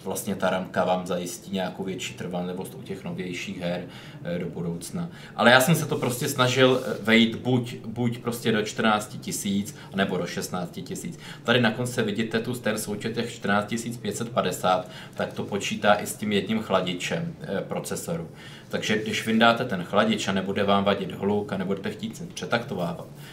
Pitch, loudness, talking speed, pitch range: 110 Hz, -26 LUFS, 170 wpm, 95-120 Hz